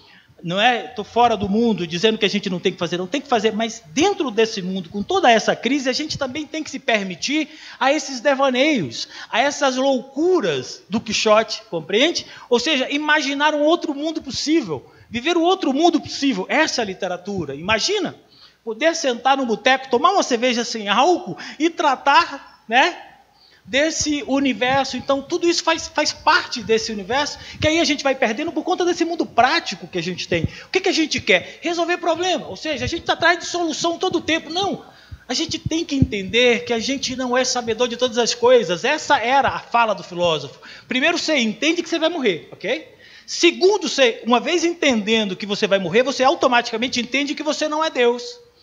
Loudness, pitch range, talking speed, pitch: -19 LUFS, 230-325 Hz, 200 wpm, 275 Hz